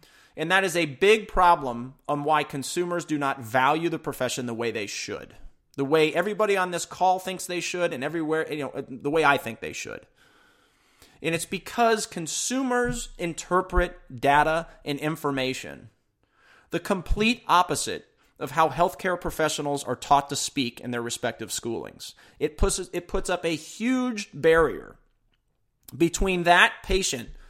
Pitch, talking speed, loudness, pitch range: 160 Hz, 155 wpm, -25 LUFS, 140-180 Hz